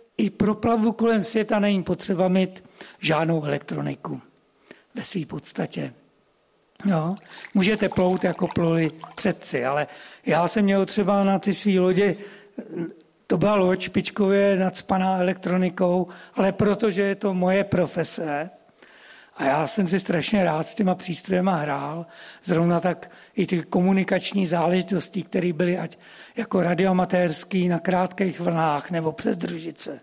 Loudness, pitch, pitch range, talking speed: -23 LUFS, 185 Hz, 175-200 Hz, 135 wpm